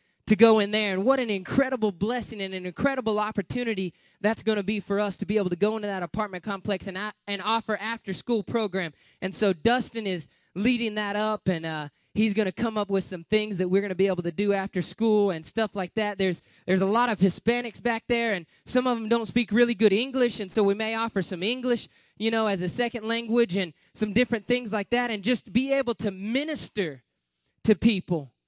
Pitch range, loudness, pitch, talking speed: 195-230 Hz, -26 LUFS, 210 Hz, 230 wpm